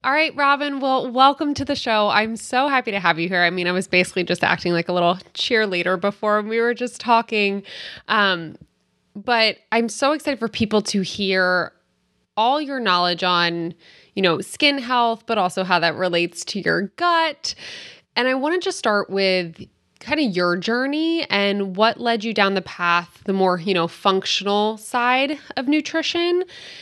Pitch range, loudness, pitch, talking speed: 180-260 Hz, -20 LUFS, 210 Hz, 185 wpm